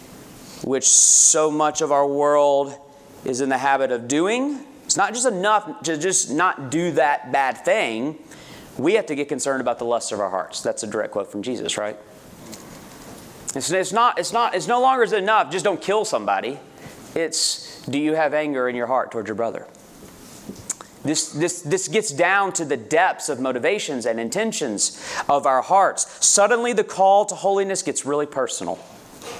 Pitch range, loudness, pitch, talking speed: 140-200 Hz, -20 LUFS, 155 Hz, 180 wpm